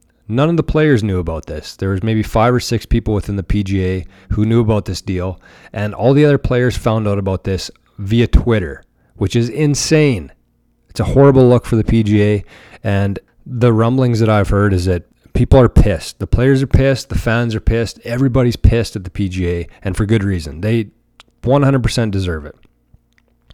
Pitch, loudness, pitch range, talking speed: 110 Hz, -15 LUFS, 95-120 Hz, 190 wpm